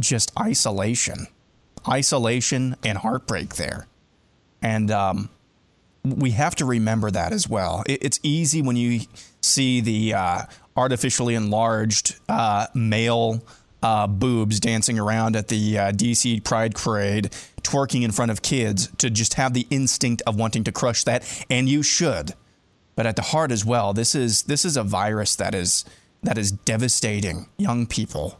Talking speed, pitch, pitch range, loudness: 155 wpm, 115 Hz, 105-125 Hz, -22 LUFS